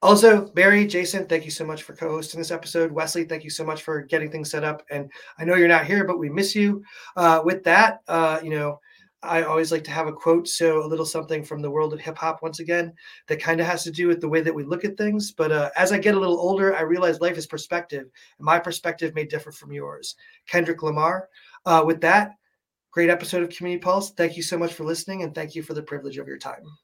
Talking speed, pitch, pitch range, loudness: 255 wpm, 165 Hz, 155-175 Hz, -22 LUFS